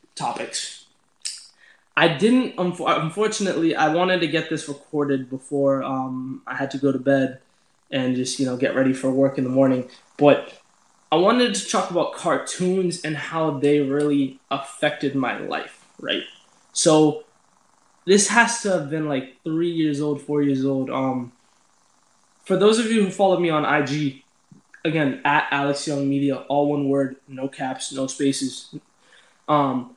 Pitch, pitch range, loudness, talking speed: 145 Hz, 135-165 Hz, -22 LUFS, 160 wpm